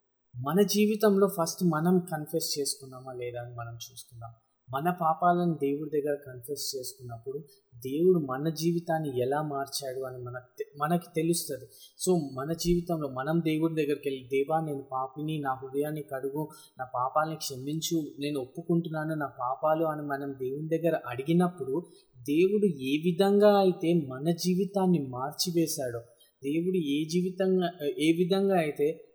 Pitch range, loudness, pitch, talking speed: 135-175 Hz, -29 LUFS, 155 Hz, 130 wpm